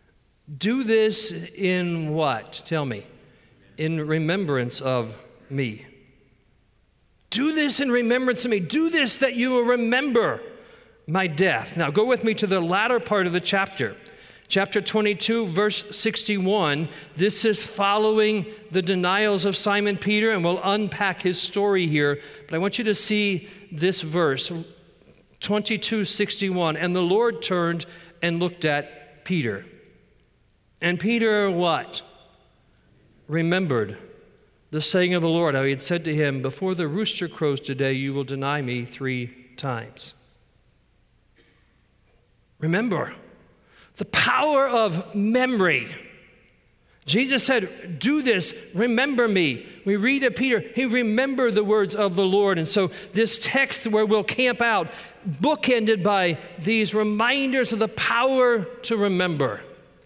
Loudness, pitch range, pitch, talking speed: -22 LUFS, 160-220 Hz, 195 Hz, 135 wpm